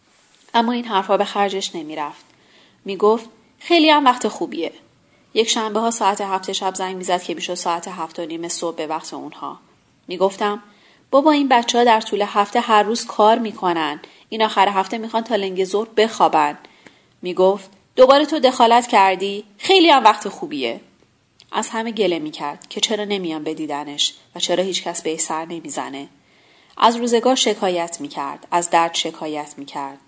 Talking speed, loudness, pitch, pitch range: 180 wpm, -17 LUFS, 195 Hz, 170-225 Hz